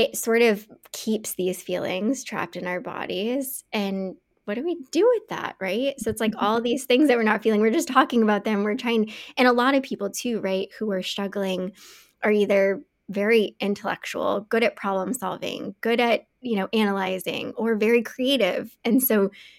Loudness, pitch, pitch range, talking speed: -24 LUFS, 220 Hz, 200-245 Hz, 195 wpm